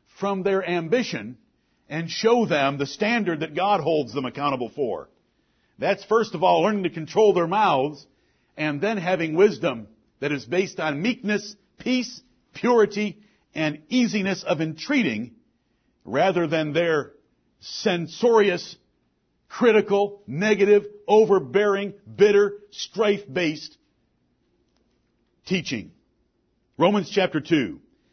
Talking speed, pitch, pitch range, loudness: 110 wpm, 195 Hz, 165-215 Hz, -23 LUFS